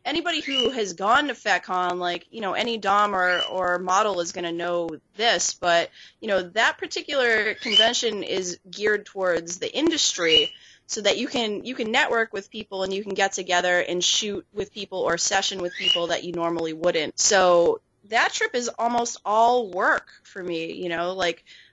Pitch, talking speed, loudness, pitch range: 195 Hz, 185 wpm, -23 LUFS, 175-230 Hz